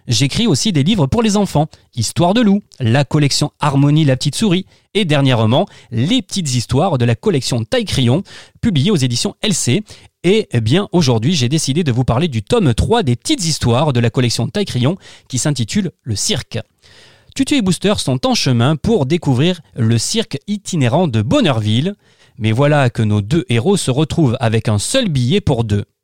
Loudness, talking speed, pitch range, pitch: -15 LUFS, 180 wpm, 120-175 Hz, 140 Hz